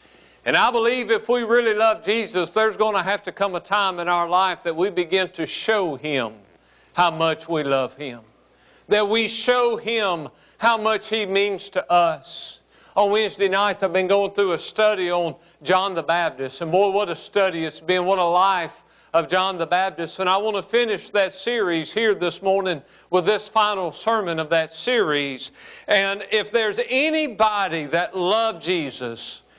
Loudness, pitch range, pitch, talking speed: -21 LUFS, 170-215 Hz, 190 Hz, 185 wpm